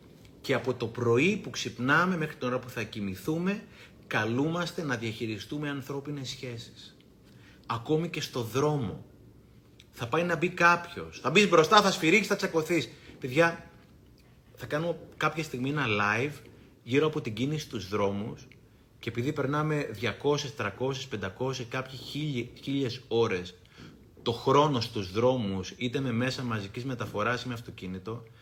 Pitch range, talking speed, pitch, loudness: 115-150 Hz, 140 wpm, 130 Hz, -29 LUFS